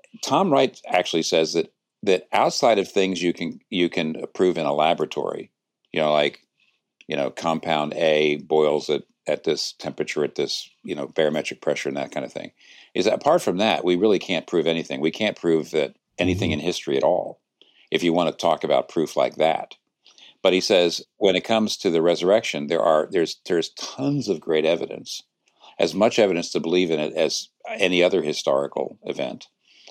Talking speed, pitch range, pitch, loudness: 195 wpm, 80-90 Hz, 85 Hz, -22 LUFS